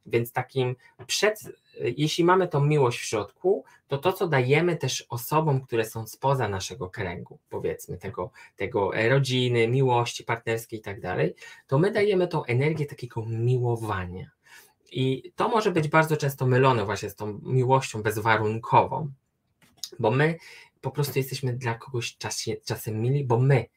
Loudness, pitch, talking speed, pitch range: -26 LUFS, 130 Hz, 150 wpm, 115-145 Hz